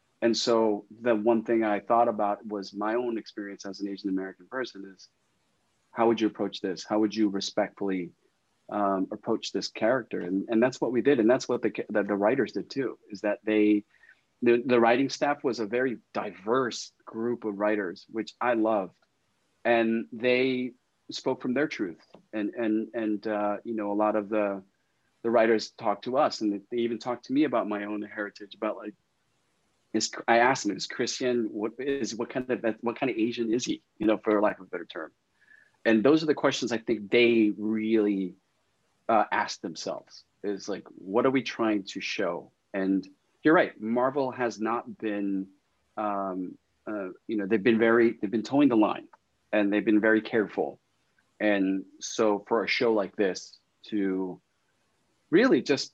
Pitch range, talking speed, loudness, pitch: 105-120 Hz, 185 wpm, -28 LUFS, 110 Hz